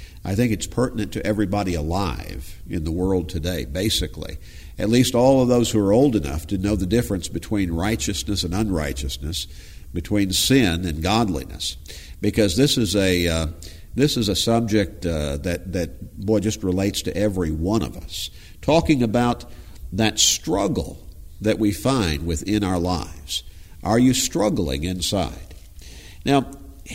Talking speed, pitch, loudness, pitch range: 150 wpm, 95 Hz, -22 LUFS, 85-110 Hz